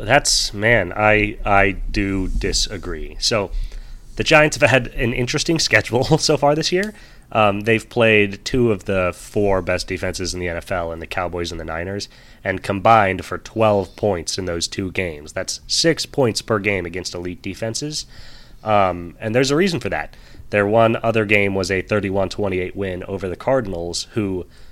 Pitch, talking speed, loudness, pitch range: 100 Hz, 175 wpm, -19 LUFS, 90-115 Hz